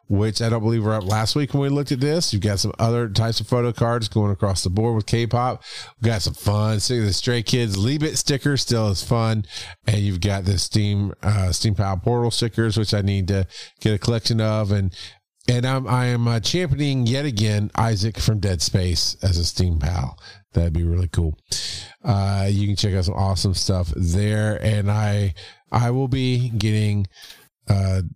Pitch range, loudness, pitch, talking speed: 100-120 Hz, -21 LUFS, 105 Hz, 200 wpm